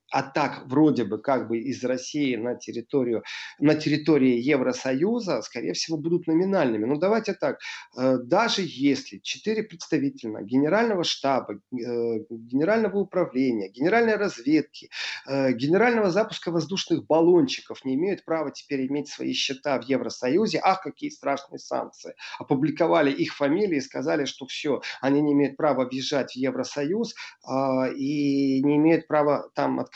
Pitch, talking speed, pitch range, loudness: 145 Hz, 135 wpm, 130-170 Hz, -25 LUFS